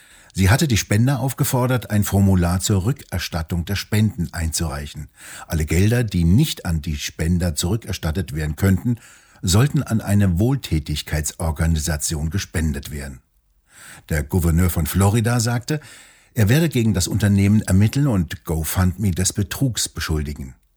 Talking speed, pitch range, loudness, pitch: 125 wpm, 80-110 Hz, -20 LUFS, 95 Hz